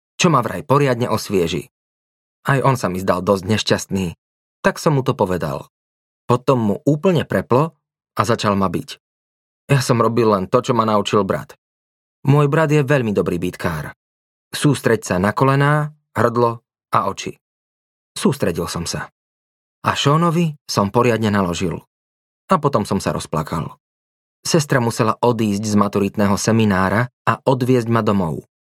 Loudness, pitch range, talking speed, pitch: -18 LUFS, 90-130 Hz, 145 wpm, 110 Hz